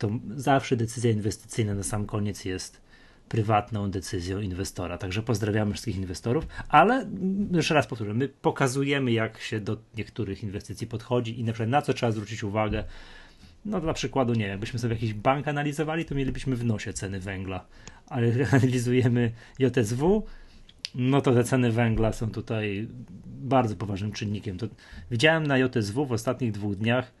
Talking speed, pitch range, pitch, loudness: 160 wpm, 105-130 Hz, 115 Hz, -27 LUFS